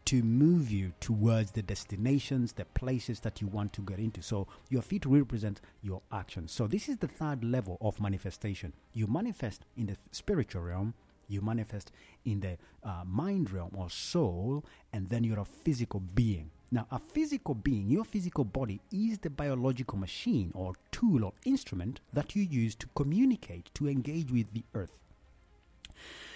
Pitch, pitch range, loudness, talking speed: 110 Hz, 95-135 Hz, -34 LUFS, 170 wpm